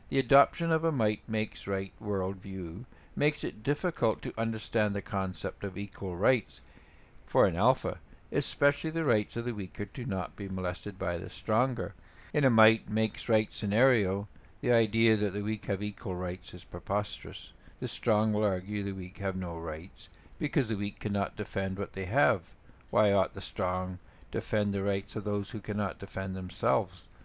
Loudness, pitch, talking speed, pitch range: -31 LUFS, 105 Hz, 175 wpm, 95-110 Hz